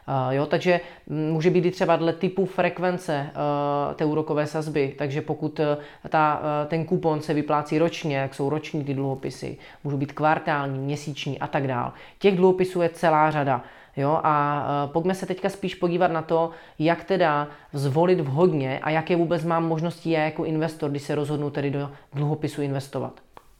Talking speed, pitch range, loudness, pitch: 175 wpm, 145-170 Hz, -24 LUFS, 155 Hz